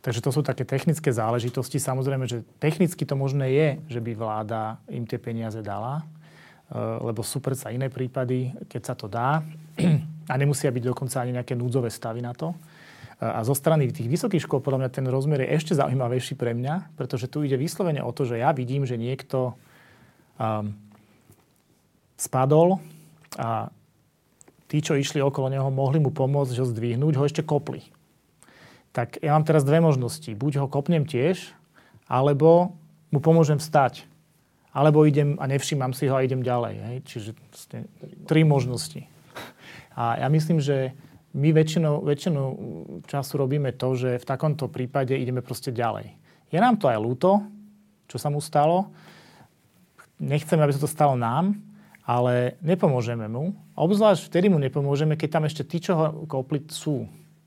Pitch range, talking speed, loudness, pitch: 125-155 Hz, 160 wpm, -25 LUFS, 140 Hz